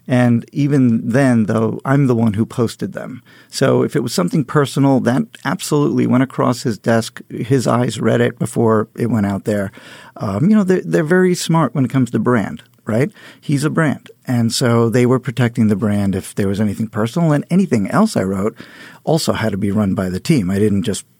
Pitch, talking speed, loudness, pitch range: 120 Hz, 210 wpm, -16 LUFS, 110-140 Hz